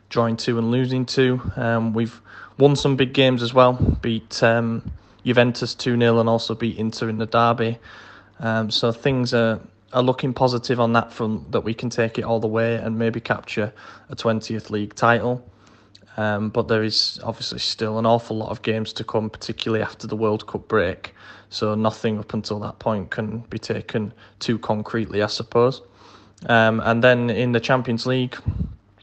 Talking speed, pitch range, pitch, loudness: 185 wpm, 110-120 Hz, 115 Hz, -22 LUFS